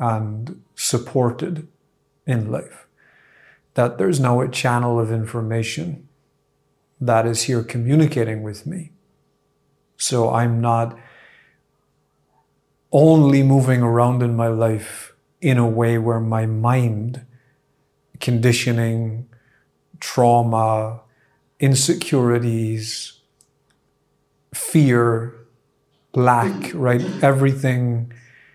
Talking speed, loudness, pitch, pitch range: 80 wpm, -19 LUFS, 120 Hz, 115-135 Hz